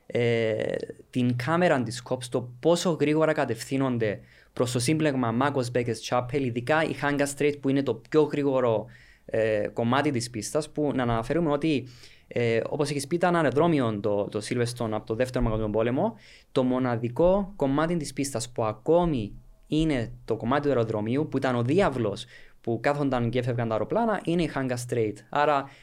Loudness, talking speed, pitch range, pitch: -26 LUFS, 170 wpm, 115-145 Hz, 130 Hz